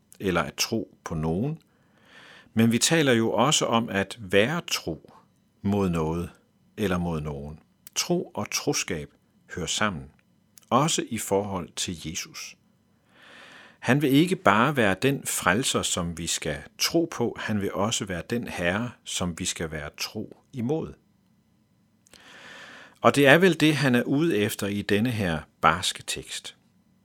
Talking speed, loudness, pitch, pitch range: 150 wpm, -25 LUFS, 100 Hz, 90-125 Hz